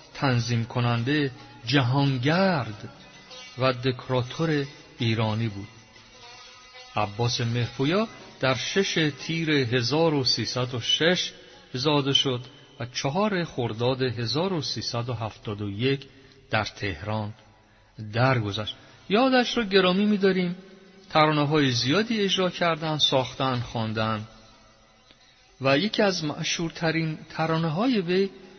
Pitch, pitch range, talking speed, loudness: 135 Hz, 120-165 Hz, 85 wpm, -25 LUFS